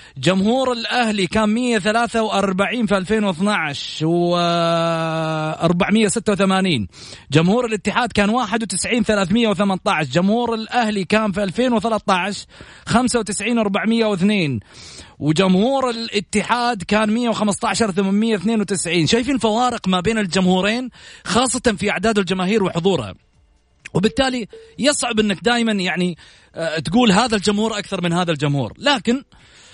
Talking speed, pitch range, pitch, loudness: 95 wpm, 185-230 Hz, 210 Hz, -18 LUFS